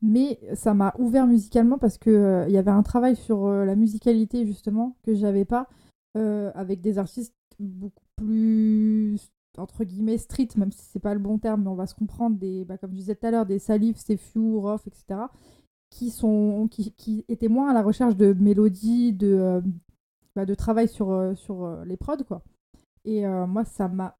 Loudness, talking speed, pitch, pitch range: -24 LUFS, 205 wpm, 215 Hz, 200-225 Hz